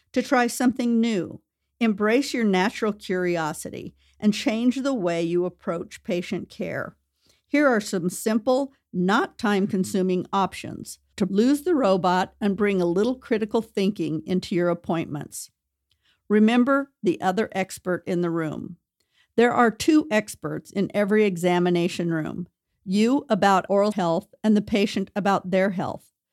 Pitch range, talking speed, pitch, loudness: 180-230 Hz, 140 wpm, 200 Hz, -23 LUFS